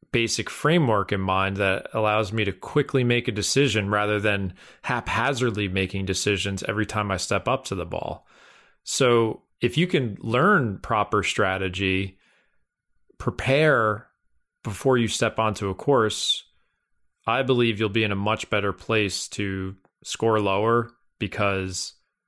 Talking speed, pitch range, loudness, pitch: 140 wpm, 95-115 Hz, -24 LUFS, 105 Hz